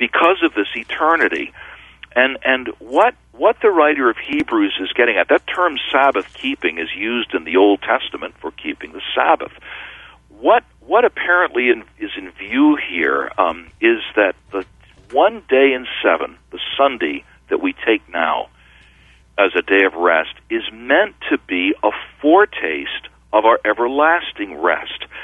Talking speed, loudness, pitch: 155 wpm, -17 LUFS, 300 Hz